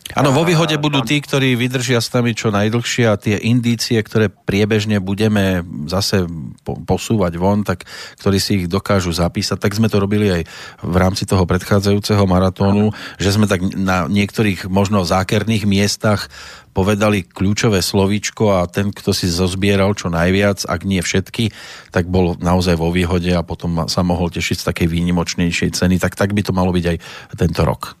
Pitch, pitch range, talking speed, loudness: 100 Hz, 90-105 Hz, 170 wpm, -17 LUFS